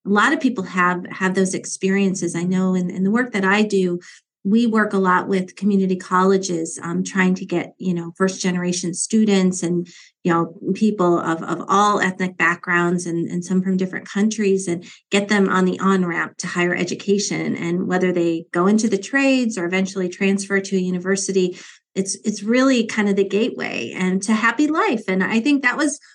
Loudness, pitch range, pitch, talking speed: -20 LUFS, 180-205 Hz, 190 Hz, 195 wpm